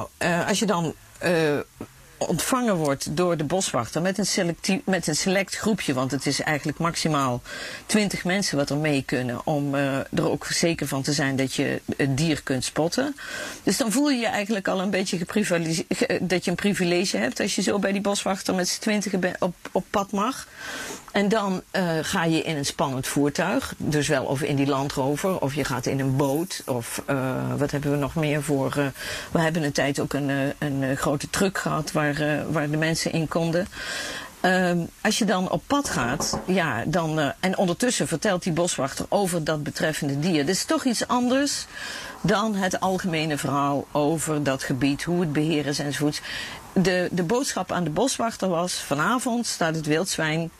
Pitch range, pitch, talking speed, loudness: 145-190 Hz, 165 Hz, 195 wpm, -24 LUFS